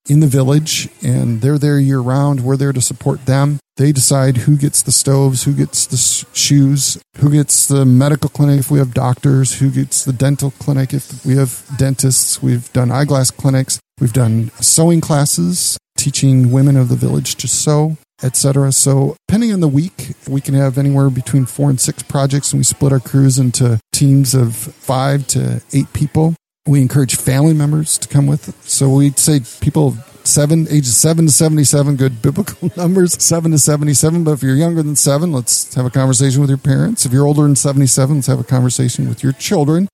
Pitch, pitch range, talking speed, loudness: 140 Hz, 130-145 Hz, 195 wpm, -13 LUFS